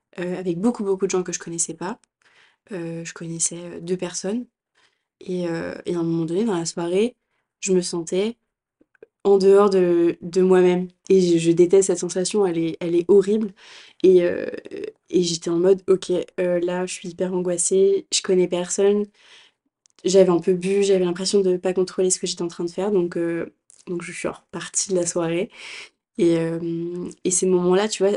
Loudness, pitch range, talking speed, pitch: -21 LUFS, 175-195 Hz, 200 wpm, 185 Hz